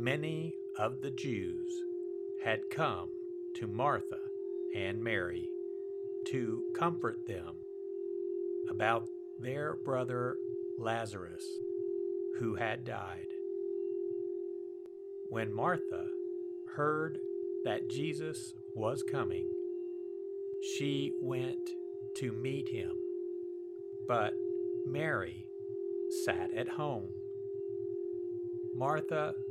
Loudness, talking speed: -37 LUFS, 75 wpm